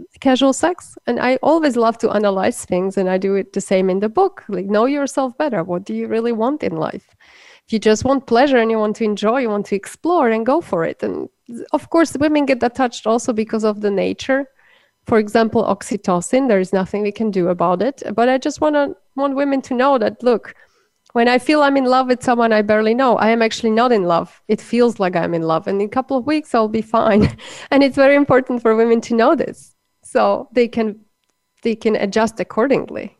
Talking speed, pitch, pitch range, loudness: 230 wpm, 230 Hz, 210-265 Hz, -17 LUFS